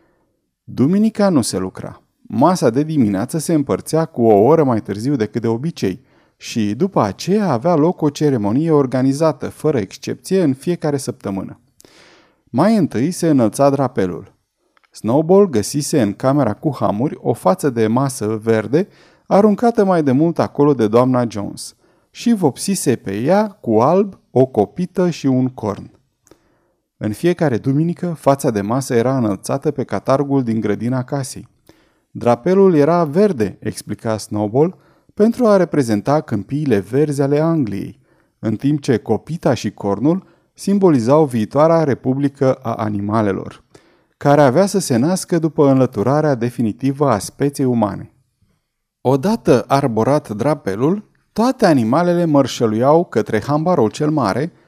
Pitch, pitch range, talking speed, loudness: 140 Hz, 115-165 Hz, 135 wpm, -17 LUFS